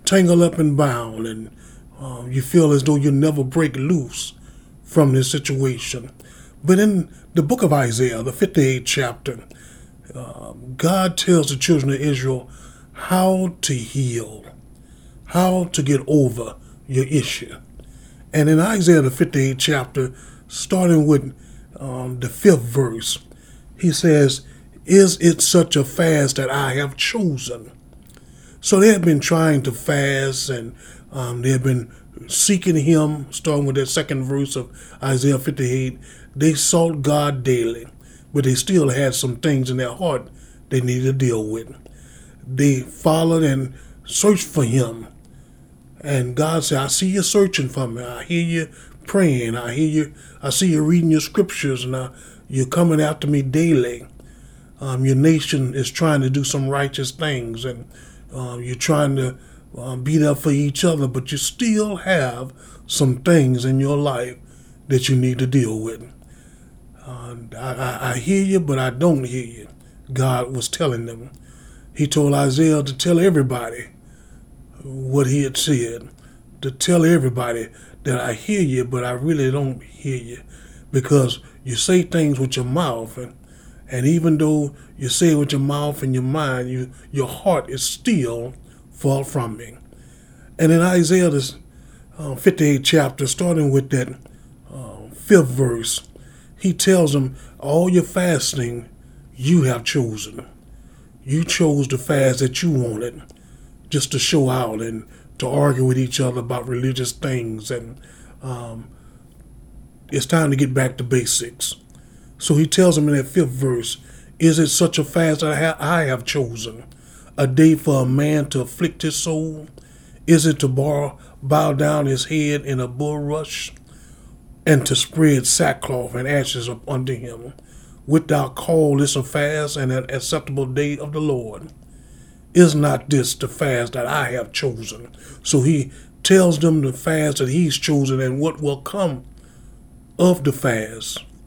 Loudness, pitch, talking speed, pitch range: -19 LUFS, 140 Hz, 160 wpm, 125-155 Hz